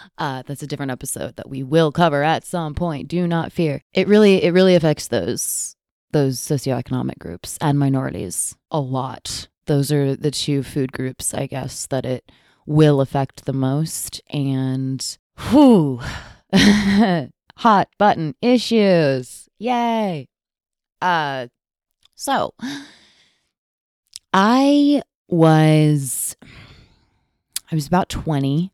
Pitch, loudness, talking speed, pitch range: 150 Hz, -19 LUFS, 115 wpm, 130-180 Hz